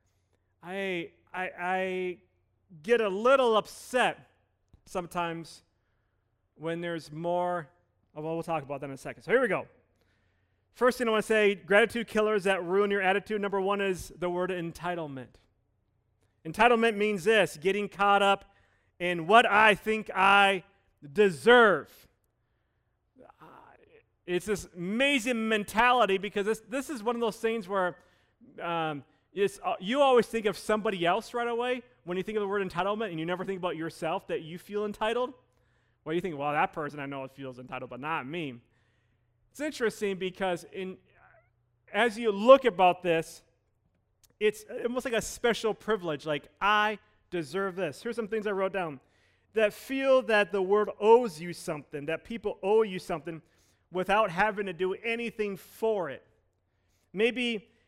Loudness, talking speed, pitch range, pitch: -28 LUFS, 160 wpm, 150-215 Hz, 185 Hz